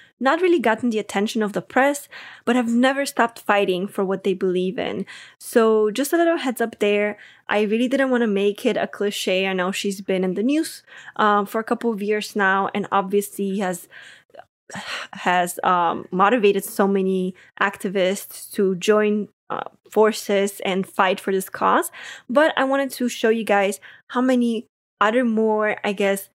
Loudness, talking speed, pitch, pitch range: -21 LUFS, 180 wpm, 210 Hz, 195-235 Hz